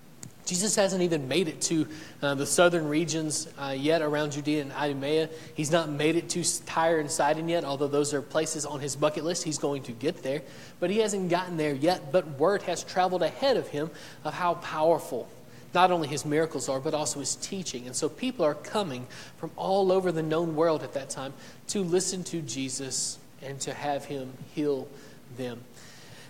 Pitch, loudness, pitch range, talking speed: 155 Hz, -28 LUFS, 140-170 Hz, 200 wpm